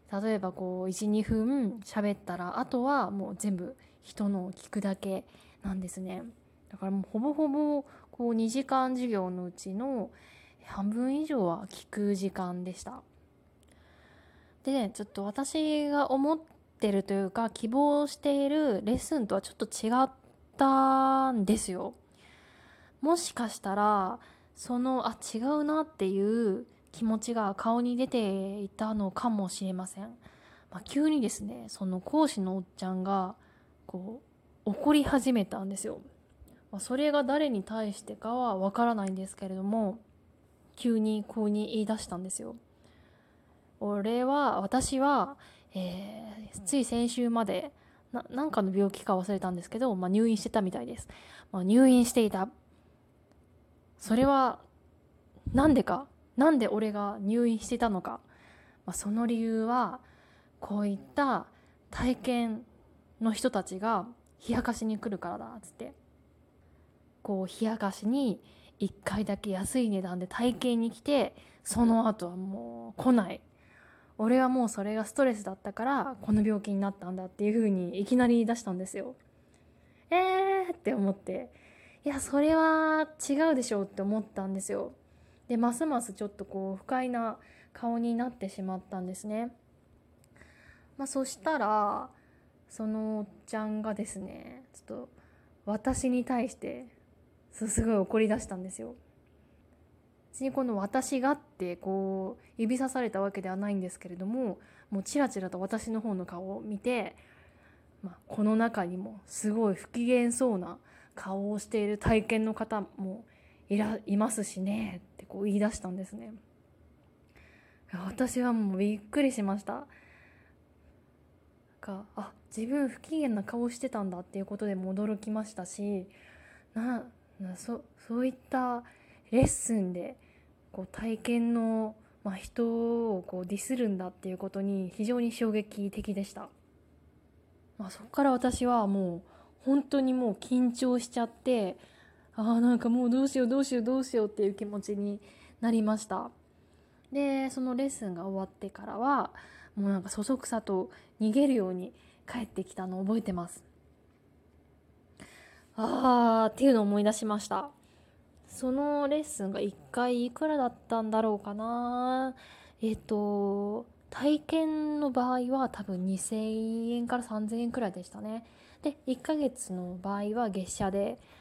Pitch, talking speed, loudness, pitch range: 220 Hz, 280 characters per minute, -31 LUFS, 195-250 Hz